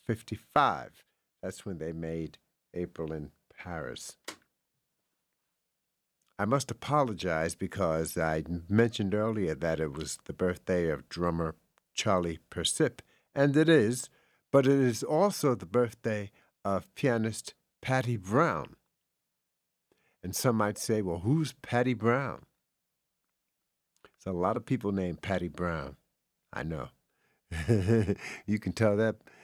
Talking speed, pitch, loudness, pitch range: 120 wpm, 105 Hz, -30 LUFS, 85-120 Hz